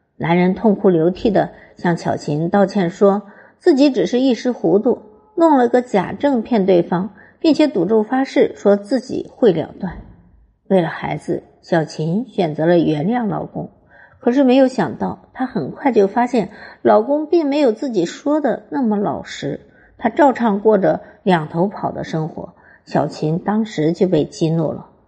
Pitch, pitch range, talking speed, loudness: 210 Hz, 175-255 Hz, 235 characters per minute, -17 LUFS